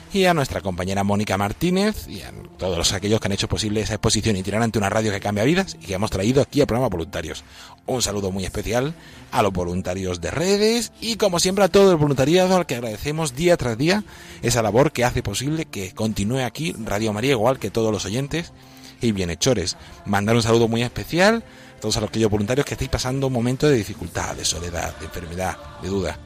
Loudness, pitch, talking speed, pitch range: -21 LUFS, 110 Hz, 215 wpm, 100-140 Hz